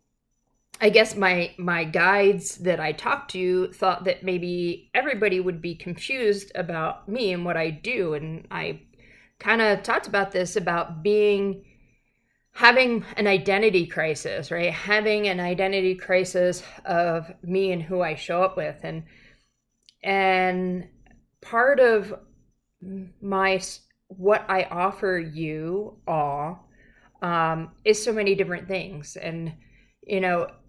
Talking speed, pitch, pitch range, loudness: 130 wpm, 185 Hz, 170-200 Hz, -24 LUFS